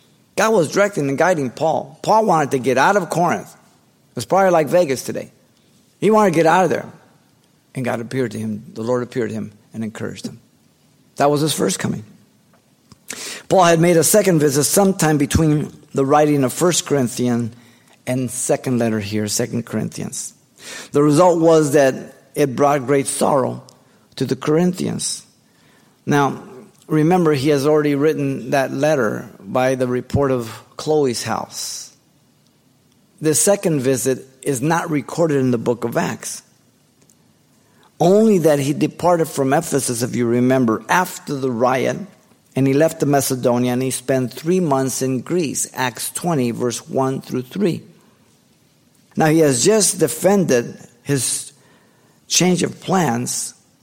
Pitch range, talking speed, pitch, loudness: 125-160 Hz, 155 wpm, 140 Hz, -18 LUFS